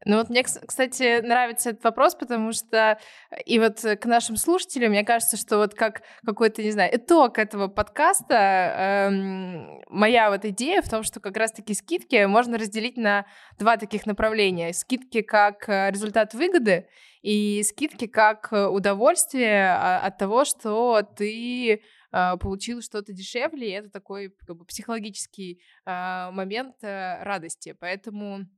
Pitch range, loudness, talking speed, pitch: 200-235 Hz, -23 LUFS, 130 wpm, 215 Hz